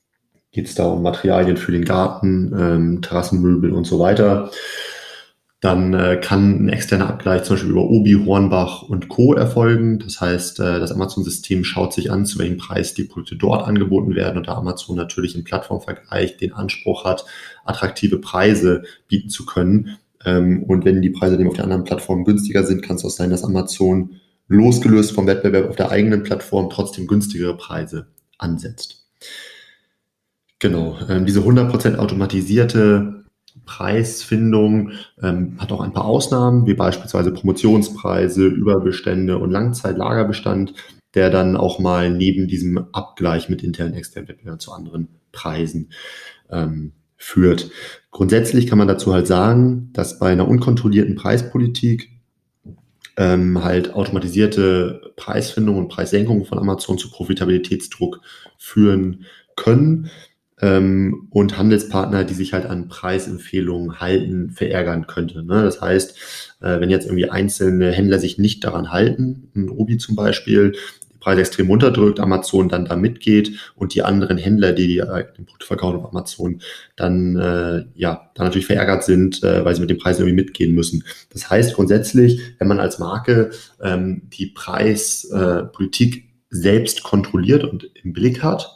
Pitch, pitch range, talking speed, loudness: 95 Hz, 90-105 Hz, 145 wpm, -17 LUFS